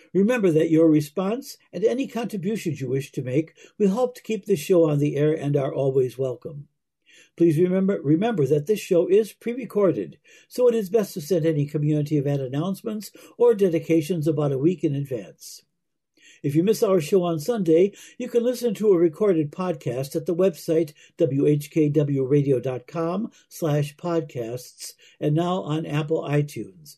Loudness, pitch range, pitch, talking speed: -23 LUFS, 150-200 Hz, 165 Hz, 165 wpm